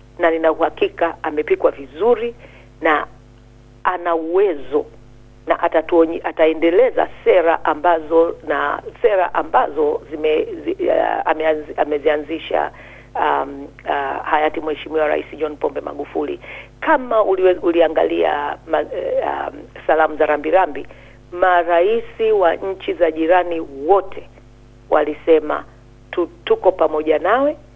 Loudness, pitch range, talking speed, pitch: -18 LUFS, 150-205 Hz, 100 wpm, 165 Hz